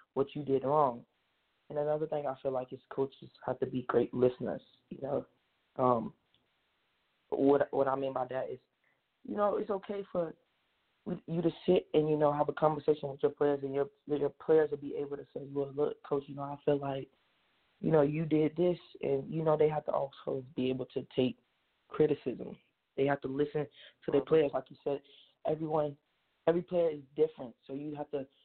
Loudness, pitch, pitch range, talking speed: -33 LUFS, 145 Hz, 135-155 Hz, 205 wpm